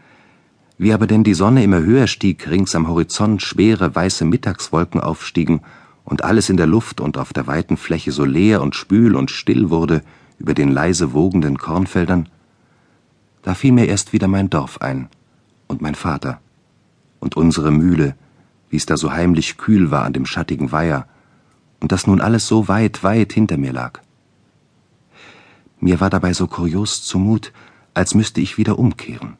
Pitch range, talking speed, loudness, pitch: 80-105 Hz, 170 wpm, -17 LUFS, 95 Hz